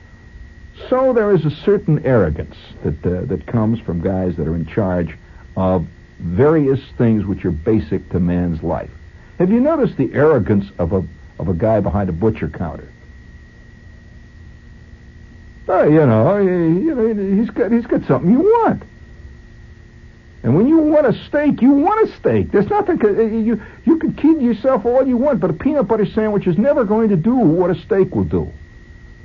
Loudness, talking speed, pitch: -16 LUFS, 175 wpm, 135 Hz